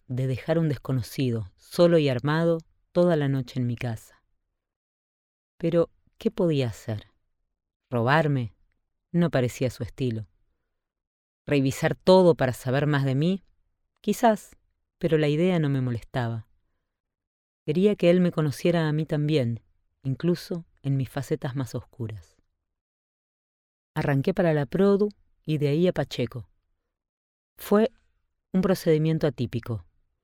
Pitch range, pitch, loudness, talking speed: 115-165 Hz, 135 Hz, -25 LUFS, 125 wpm